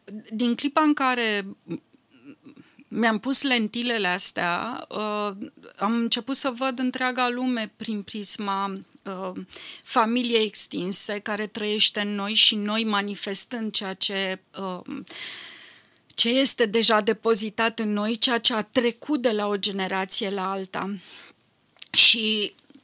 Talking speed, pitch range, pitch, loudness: 115 wpm, 200-245 Hz, 220 Hz, -22 LUFS